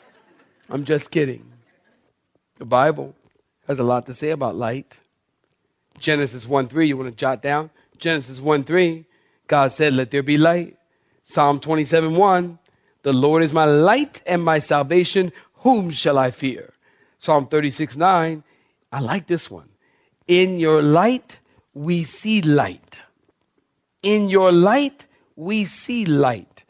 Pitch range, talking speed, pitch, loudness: 140-175 Hz, 140 wpm, 155 Hz, -19 LUFS